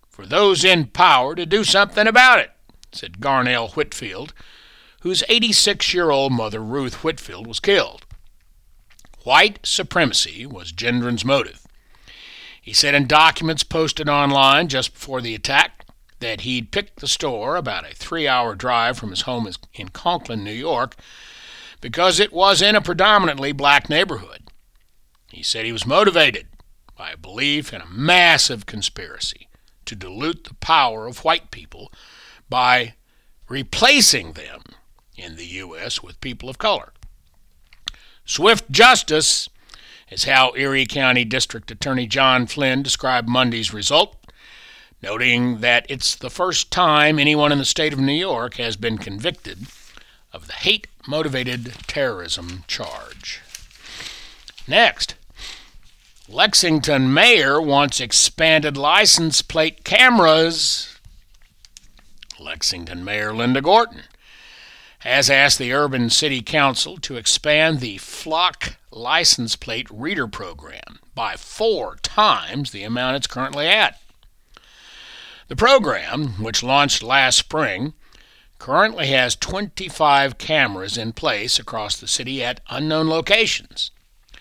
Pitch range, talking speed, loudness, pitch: 115-160 Hz, 125 wpm, -17 LUFS, 135 Hz